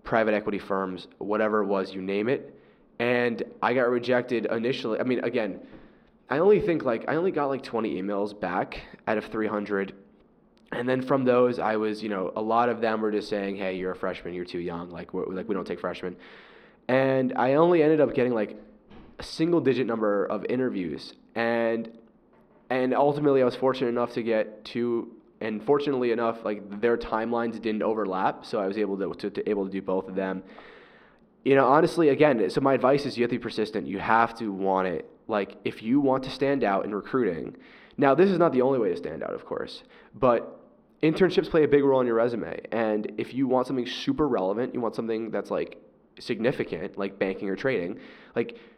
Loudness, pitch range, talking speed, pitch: -26 LUFS, 105-130 Hz, 210 wpm, 115 Hz